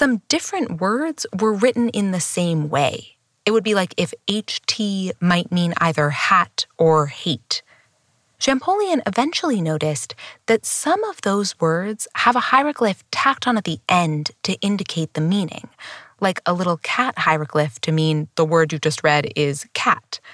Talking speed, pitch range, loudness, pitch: 160 wpm, 160-235 Hz, -20 LUFS, 185 Hz